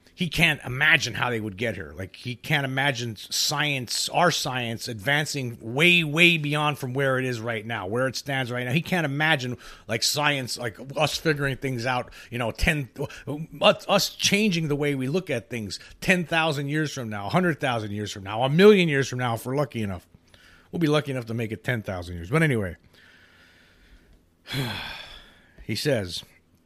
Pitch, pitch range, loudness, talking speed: 130 Hz, 115-150 Hz, -24 LUFS, 180 wpm